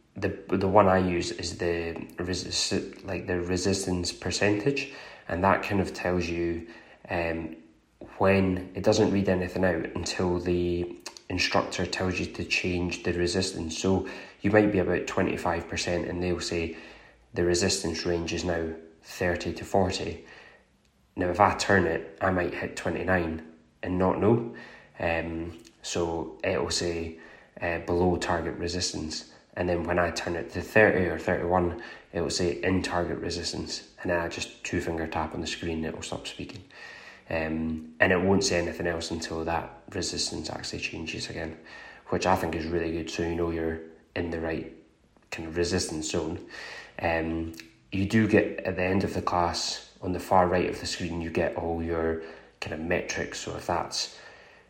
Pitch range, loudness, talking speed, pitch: 85-90 Hz, -28 LUFS, 180 wpm, 85 Hz